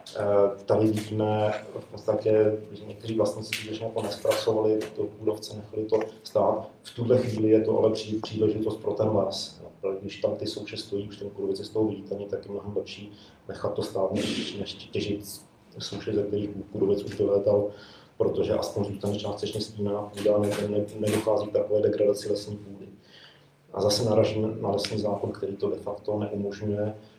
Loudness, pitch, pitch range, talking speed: -28 LUFS, 105 Hz, 100-110 Hz, 170 wpm